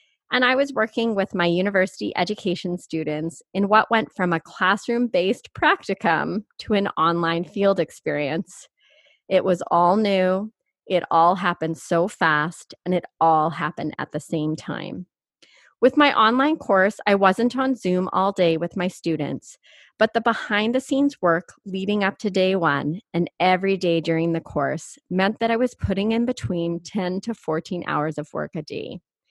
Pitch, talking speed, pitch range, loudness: 185 Hz, 170 wpm, 165-220 Hz, -22 LUFS